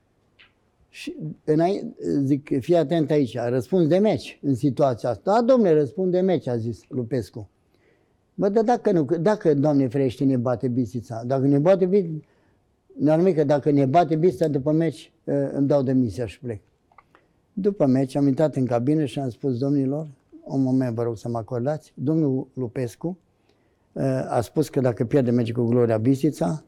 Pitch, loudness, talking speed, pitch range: 140 Hz, -22 LUFS, 165 wpm, 125-160 Hz